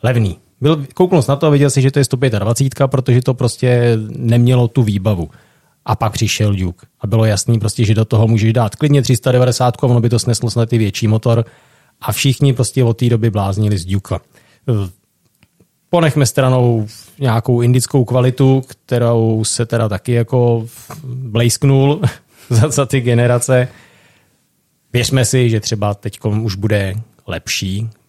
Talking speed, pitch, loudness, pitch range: 155 wpm, 120 Hz, -15 LUFS, 110-130 Hz